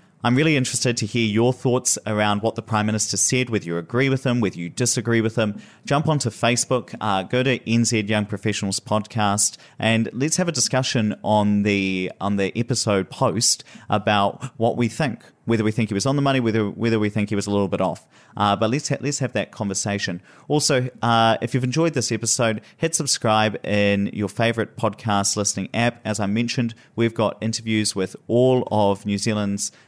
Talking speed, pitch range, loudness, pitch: 200 wpm, 105-125 Hz, -21 LUFS, 110 Hz